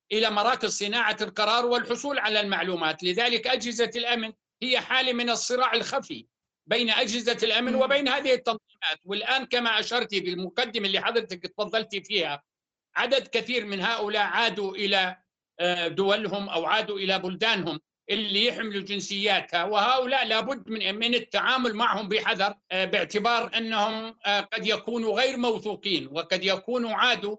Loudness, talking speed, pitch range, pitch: -25 LUFS, 130 wpm, 200-240 Hz, 220 Hz